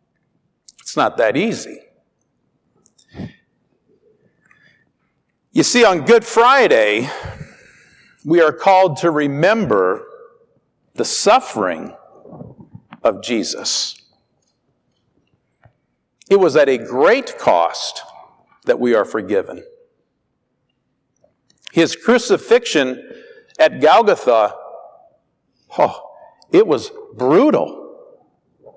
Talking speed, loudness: 75 wpm, -15 LUFS